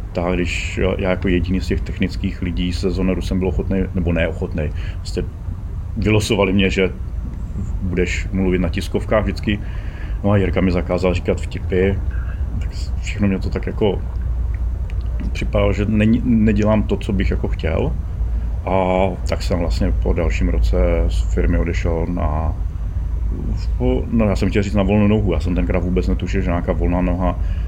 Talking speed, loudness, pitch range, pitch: 160 wpm, -20 LUFS, 85-95 Hz, 90 Hz